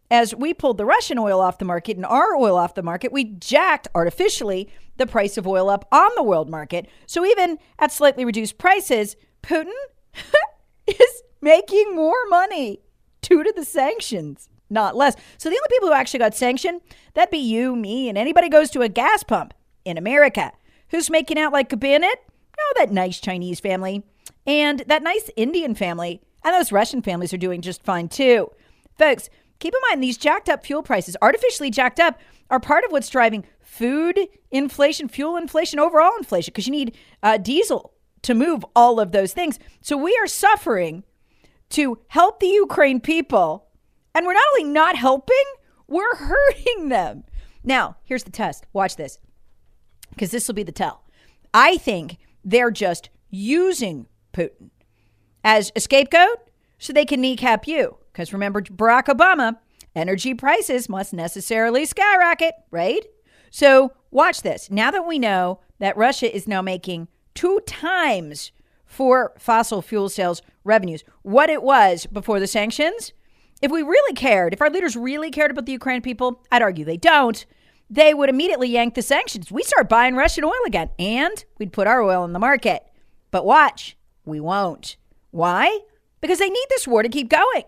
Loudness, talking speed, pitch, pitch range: -19 LUFS, 175 wpm, 260 Hz, 205-320 Hz